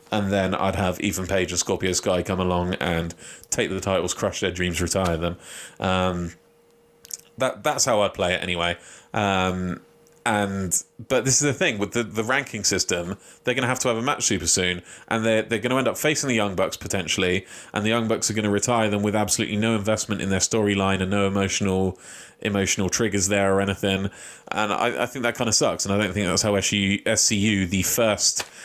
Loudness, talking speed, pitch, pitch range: -23 LUFS, 220 wpm, 100 Hz, 95-110 Hz